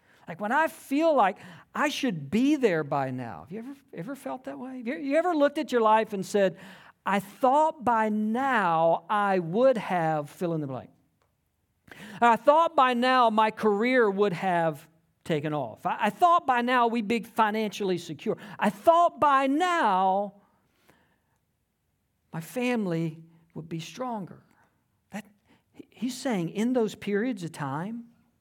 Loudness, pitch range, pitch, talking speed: -26 LUFS, 175-255 Hz, 215 Hz, 150 wpm